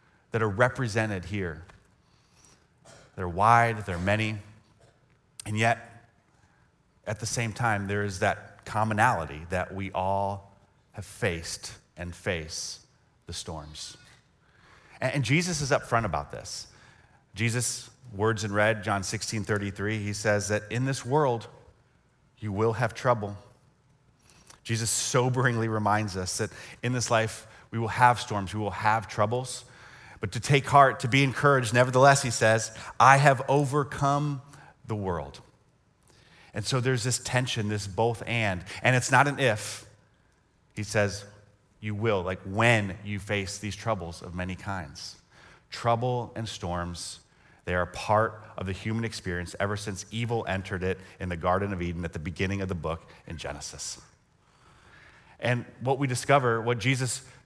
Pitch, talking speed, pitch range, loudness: 110 Hz, 150 wpm, 100-125 Hz, -27 LUFS